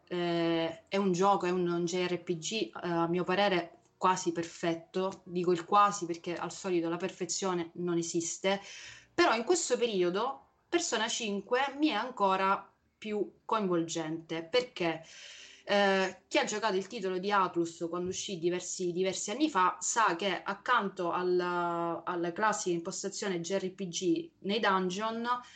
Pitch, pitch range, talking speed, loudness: 185 Hz, 175-205 Hz, 140 wpm, -31 LUFS